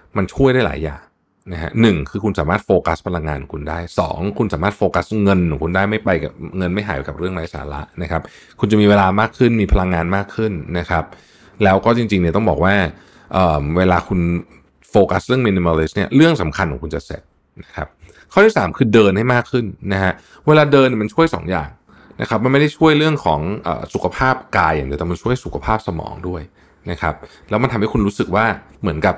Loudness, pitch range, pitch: -17 LUFS, 85-110 Hz, 95 Hz